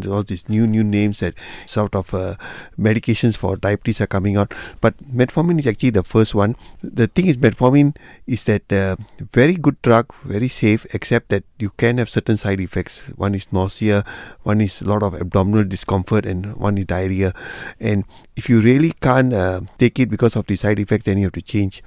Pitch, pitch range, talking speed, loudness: 105 Hz, 100-120 Hz, 205 wpm, -18 LUFS